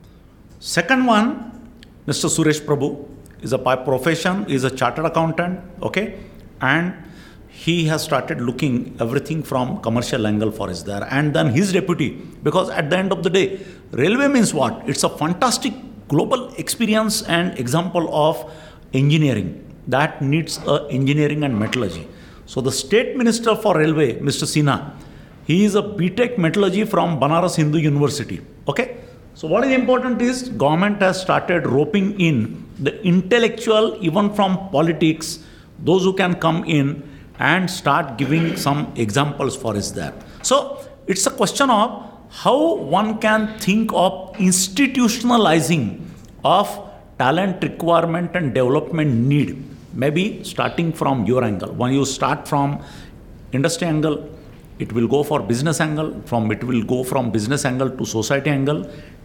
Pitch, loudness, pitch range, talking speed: 160 Hz, -19 LUFS, 135-190 Hz, 145 wpm